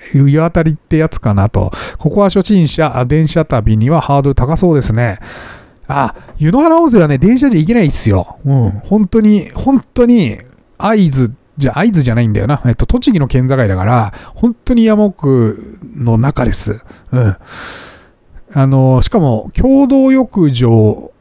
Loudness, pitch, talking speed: -12 LUFS, 140 Hz, 295 characters per minute